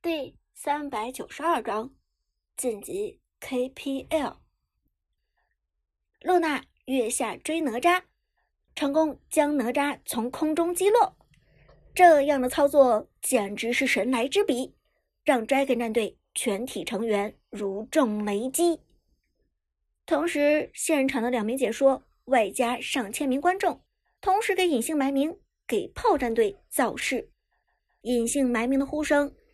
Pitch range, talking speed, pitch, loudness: 245-320 Hz, 190 characters per minute, 275 Hz, -26 LUFS